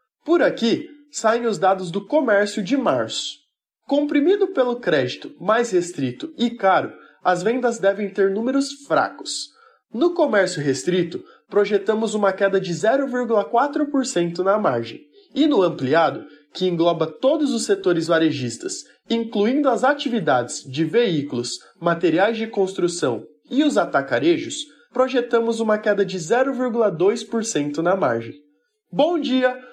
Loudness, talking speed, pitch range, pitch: -21 LUFS, 125 wpm, 185-275 Hz, 225 Hz